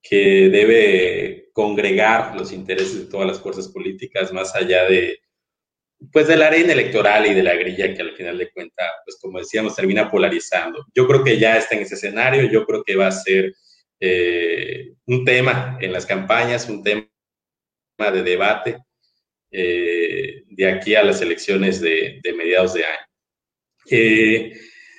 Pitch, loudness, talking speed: 165 Hz, -17 LUFS, 165 wpm